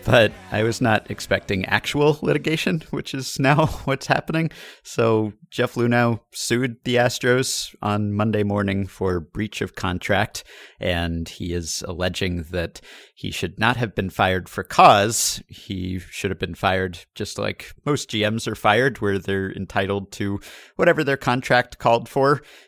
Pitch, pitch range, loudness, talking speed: 110 Hz, 95-130 Hz, -22 LUFS, 155 wpm